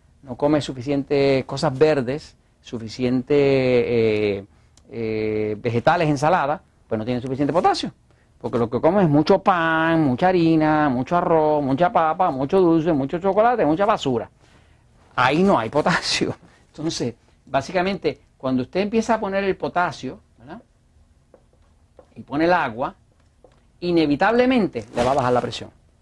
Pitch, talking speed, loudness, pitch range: 145 Hz, 130 wpm, -20 LUFS, 125-175 Hz